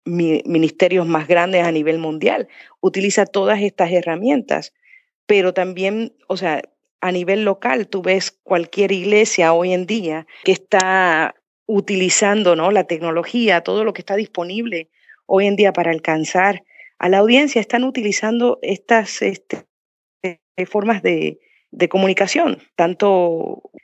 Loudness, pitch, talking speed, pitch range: -17 LUFS, 190 Hz, 130 wpm, 175-210 Hz